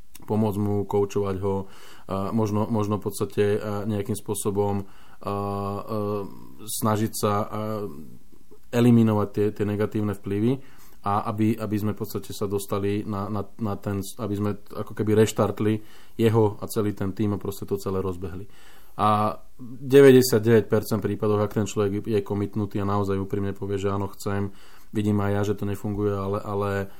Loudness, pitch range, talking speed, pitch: -25 LUFS, 100-110 Hz, 150 wpm, 105 Hz